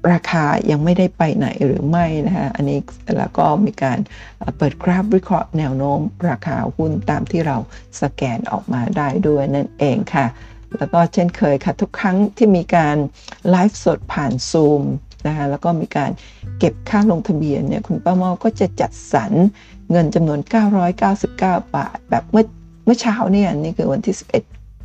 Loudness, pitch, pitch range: -18 LUFS, 170 Hz, 145-195 Hz